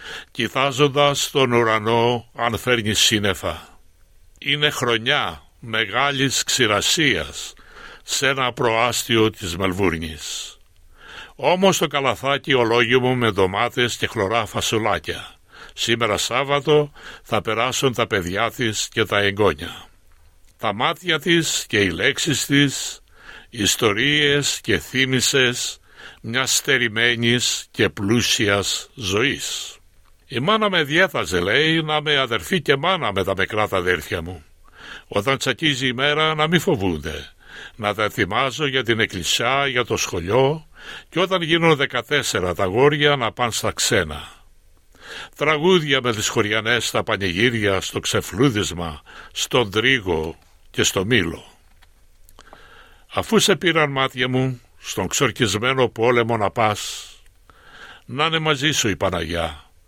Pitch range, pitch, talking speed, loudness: 100-140 Hz, 120 Hz, 120 wpm, -19 LUFS